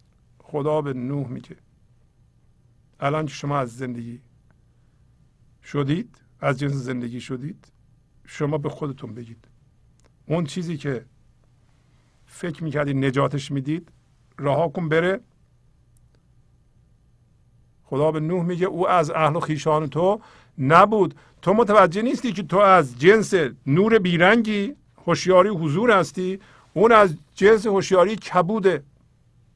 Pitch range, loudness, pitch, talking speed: 130-180 Hz, -21 LUFS, 150 Hz, 115 wpm